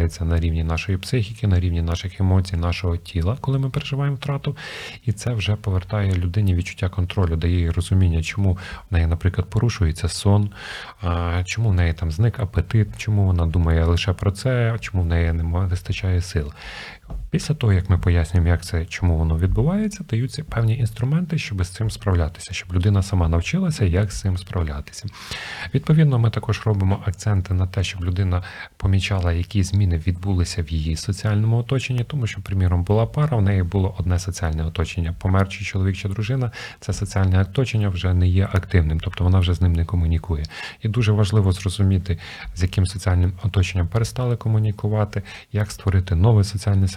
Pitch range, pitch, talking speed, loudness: 90-105 Hz, 95 Hz, 170 wpm, -22 LUFS